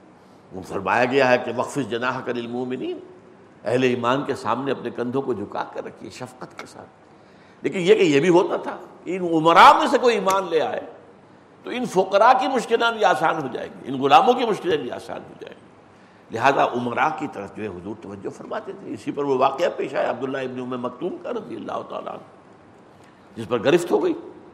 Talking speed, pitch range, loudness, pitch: 205 wpm, 120-200 Hz, -21 LUFS, 135 Hz